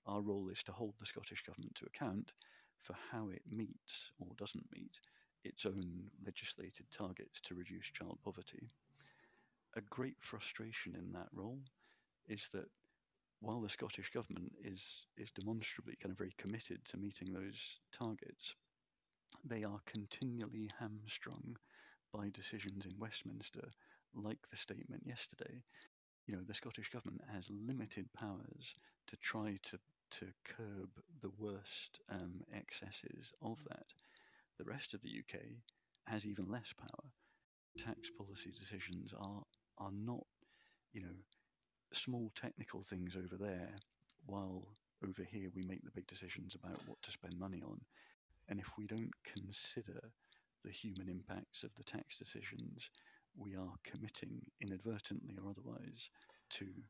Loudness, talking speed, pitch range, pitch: -49 LUFS, 140 wpm, 95-110 Hz, 100 Hz